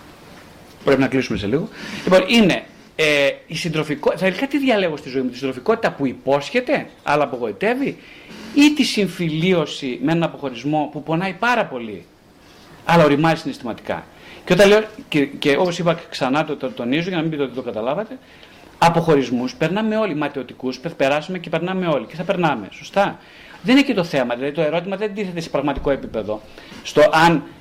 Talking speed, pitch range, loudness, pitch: 175 wpm, 140-195 Hz, -19 LUFS, 165 Hz